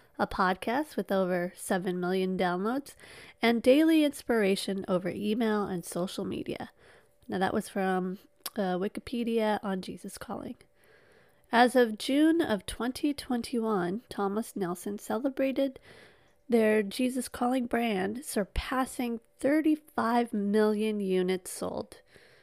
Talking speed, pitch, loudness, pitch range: 110 wpm, 215 Hz, -29 LUFS, 195-255 Hz